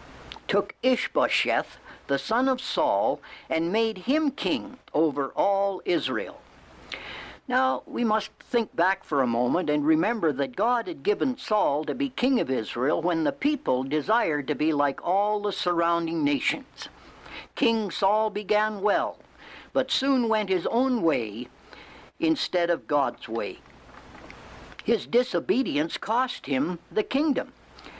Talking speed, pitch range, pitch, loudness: 135 wpm, 170-260 Hz, 220 Hz, -26 LUFS